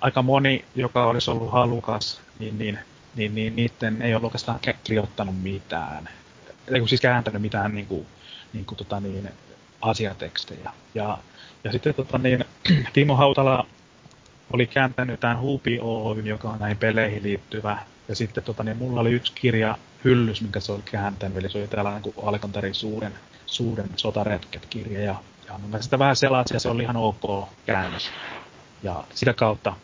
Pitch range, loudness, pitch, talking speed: 105-125 Hz, -25 LUFS, 110 Hz, 150 wpm